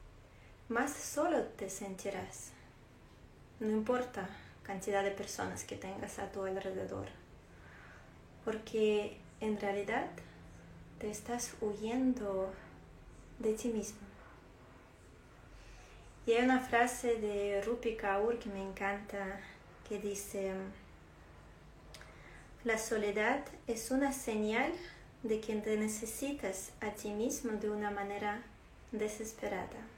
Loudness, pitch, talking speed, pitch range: -37 LUFS, 210 Hz, 100 wpm, 195-230 Hz